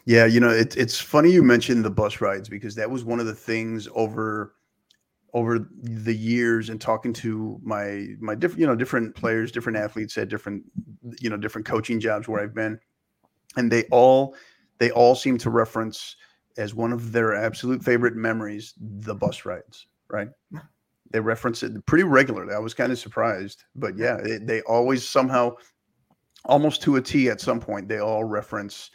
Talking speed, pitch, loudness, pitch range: 185 wpm, 115 Hz, -23 LUFS, 110-120 Hz